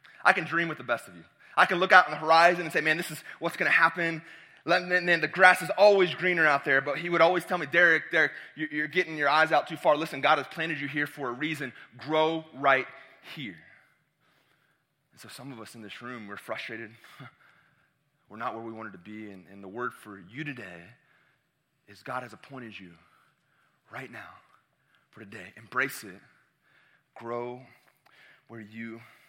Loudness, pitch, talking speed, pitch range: -25 LUFS, 155 Hz, 200 wpm, 125-170 Hz